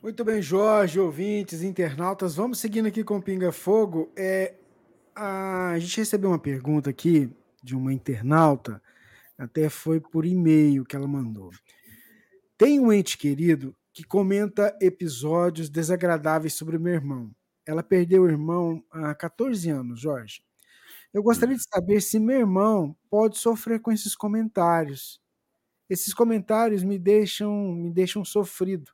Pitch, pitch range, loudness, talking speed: 185 Hz, 155-210 Hz, -24 LUFS, 140 wpm